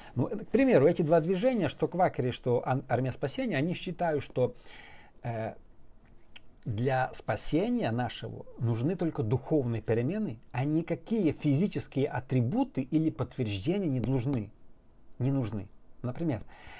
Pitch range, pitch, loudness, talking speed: 125-165 Hz, 135 Hz, -30 LUFS, 120 wpm